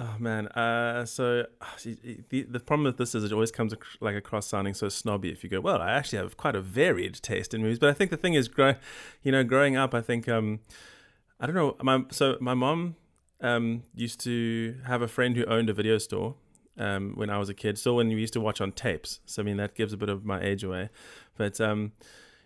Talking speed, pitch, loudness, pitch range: 240 wpm, 115 Hz, -28 LUFS, 105-125 Hz